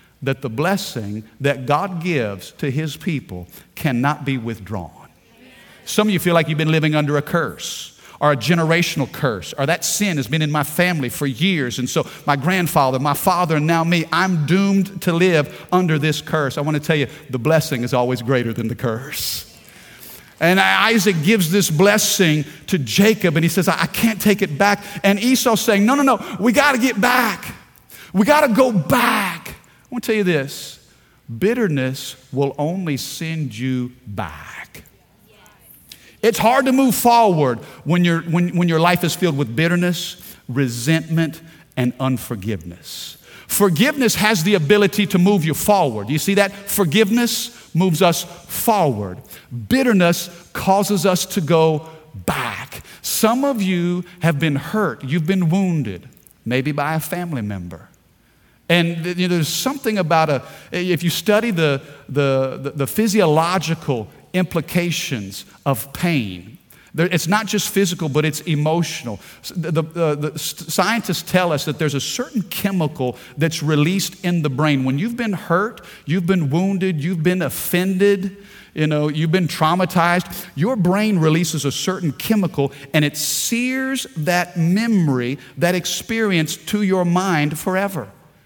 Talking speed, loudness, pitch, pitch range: 155 wpm, -18 LUFS, 165 Hz, 145-190 Hz